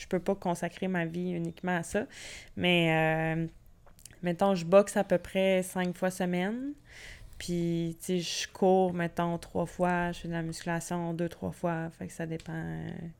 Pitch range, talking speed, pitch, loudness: 165-185 Hz, 190 wpm, 175 Hz, -31 LUFS